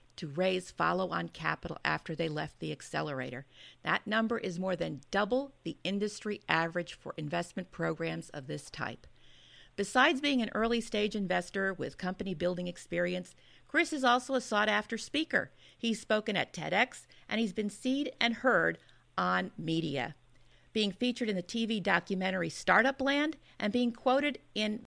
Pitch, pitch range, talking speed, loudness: 200 Hz, 170-235 Hz, 160 wpm, -32 LUFS